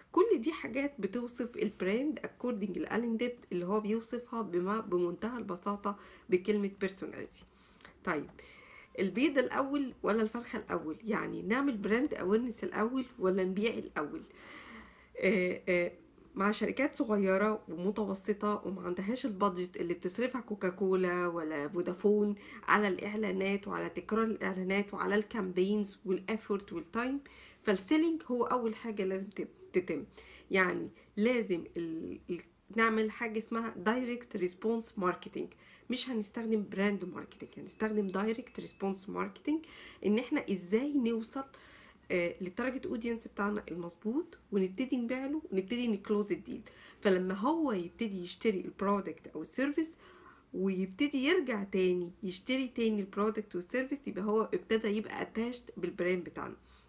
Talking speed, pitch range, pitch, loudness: 115 wpm, 185-240 Hz, 210 Hz, -34 LUFS